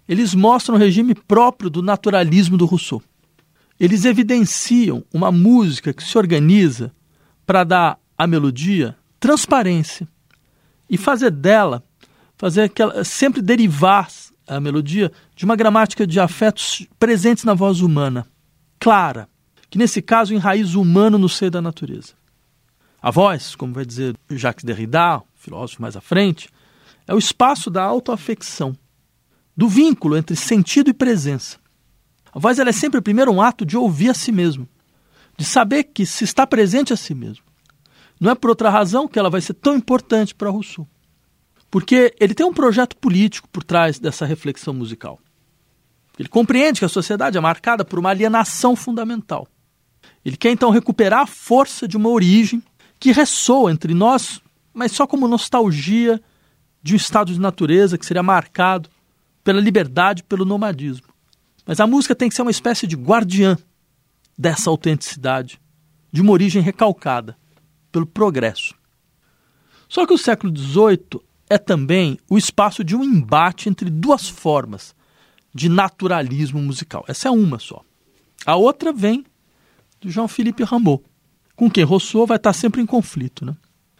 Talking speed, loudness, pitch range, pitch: 155 wpm, -16 LUFS, 155-230 Hz, 195 Hz